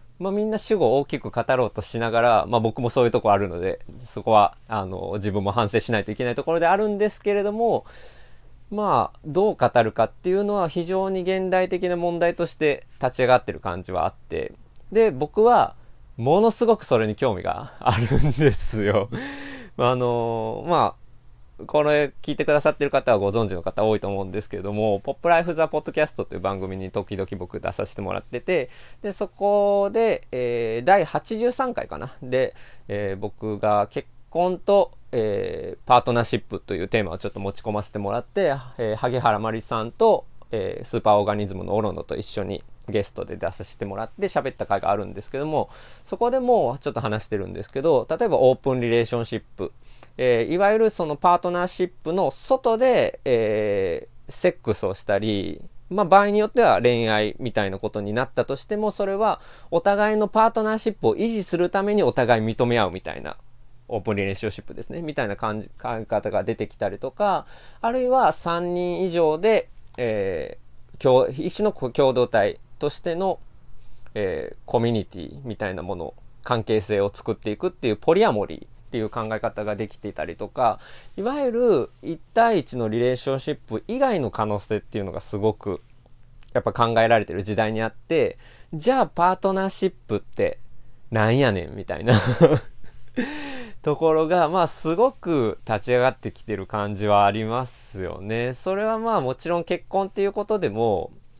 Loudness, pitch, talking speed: -23 LUFS, 130 Hz, 375 characters per minute